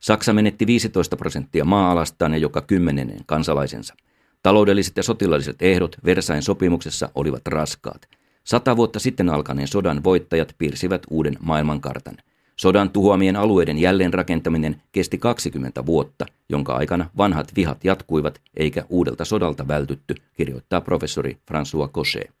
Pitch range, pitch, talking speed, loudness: 75-100 Hz, 85 Hz, 125 wpm, -21 LUFS